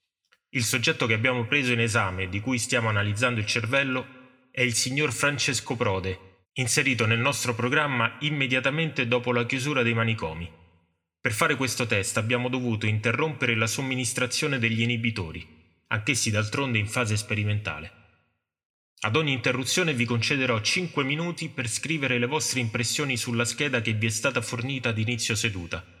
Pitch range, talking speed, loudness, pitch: 110-130 Hz, 150 wpm, -25 LUFS, 120 Hz